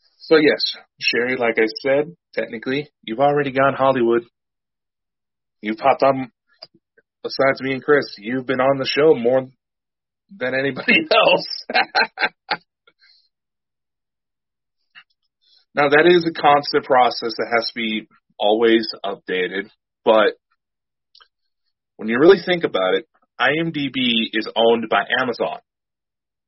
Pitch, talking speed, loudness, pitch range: 135 Hz, 115 wpm, -18 LUFS, 115-150 Hz